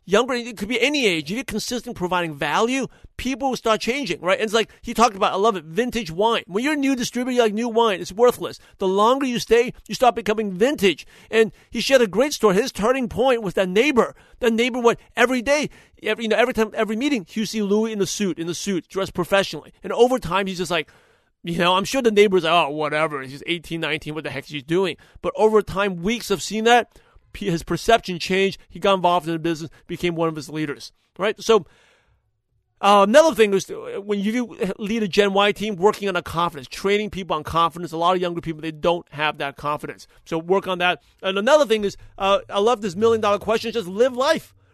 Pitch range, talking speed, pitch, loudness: 170-230 Hz, 235 wpm, 200 Hz, -21 LUFS